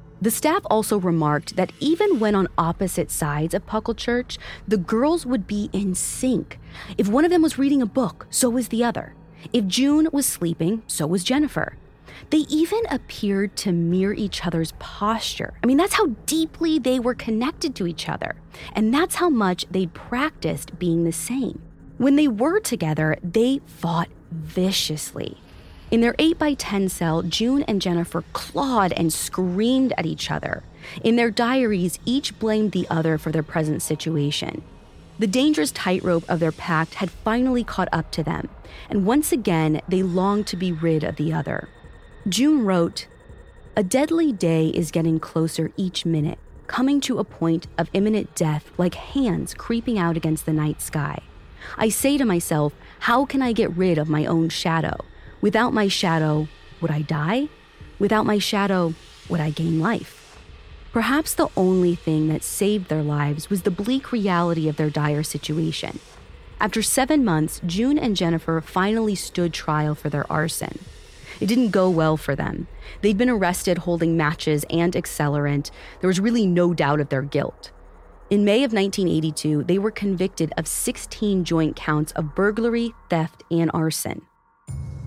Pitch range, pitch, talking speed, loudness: 160-235 Hz, 185 Hz, 165 wpm, -22 LUFS